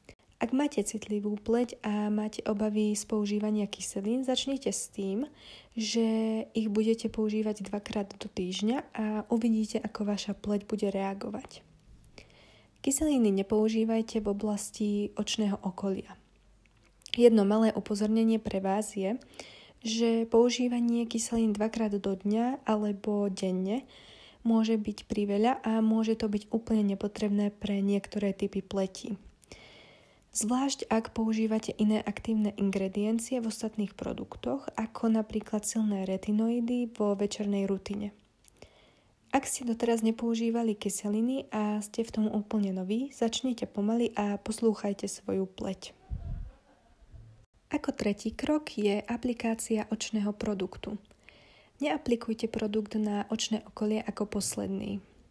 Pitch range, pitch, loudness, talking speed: 205-230 Hz, 215 Hz, -31 LUFS, 115 wpm